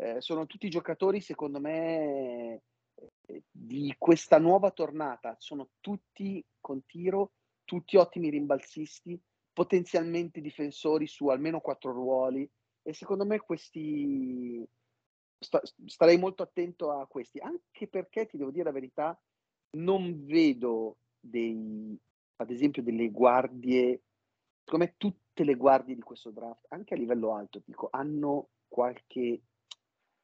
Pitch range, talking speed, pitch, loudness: 125-170 Hz, 115 wpm, 145 Hz, -30 LUFS